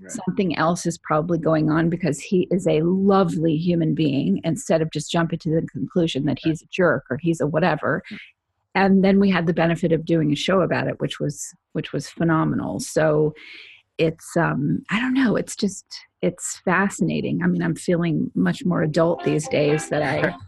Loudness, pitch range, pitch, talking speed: -21 LUFS, 155-180 Hz, 165 Hz, 195 wpm